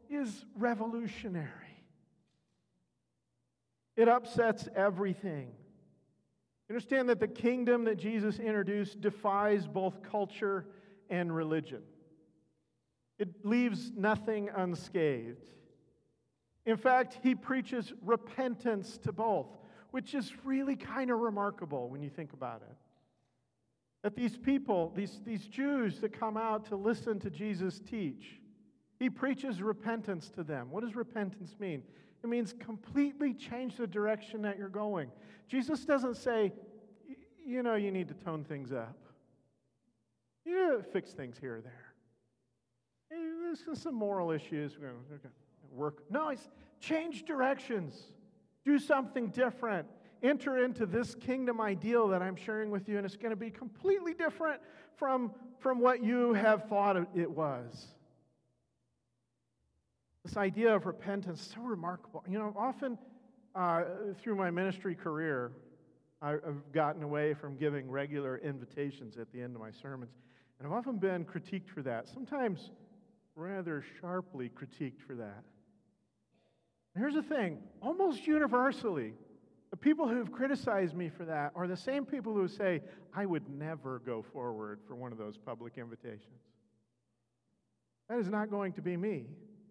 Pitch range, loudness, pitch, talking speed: 150-235 Hz, -35 LUFS, 200 Hz, 140 wpm